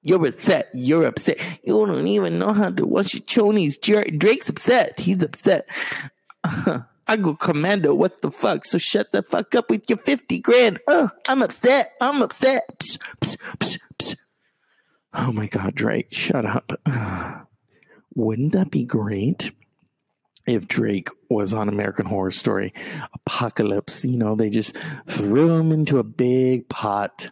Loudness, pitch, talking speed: -21 LUFS, 150 Hz, 155 wpm